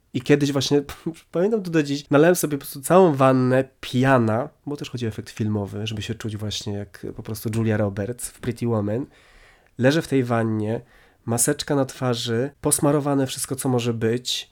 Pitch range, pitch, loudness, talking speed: 115-145 Hz, 130 Hz, -22 LUFS, 185 wpm